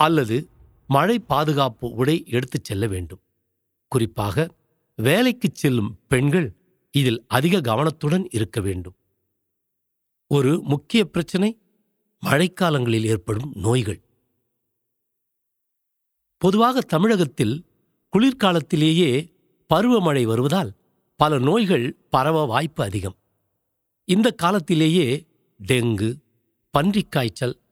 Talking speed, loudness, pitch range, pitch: 80 wpm, -21 LUFS, 115-175 Hz, 140 Hz